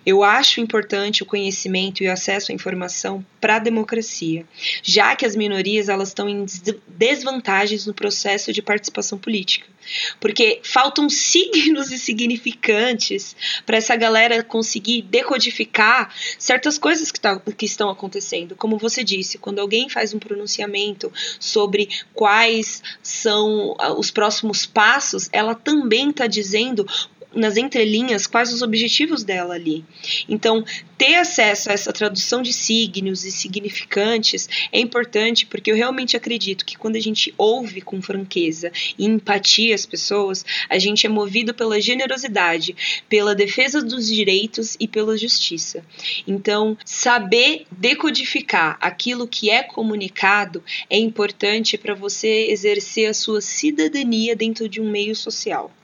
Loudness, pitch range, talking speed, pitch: -18 LUFS, 205-240 Hz, 140 wpm, 220 Hz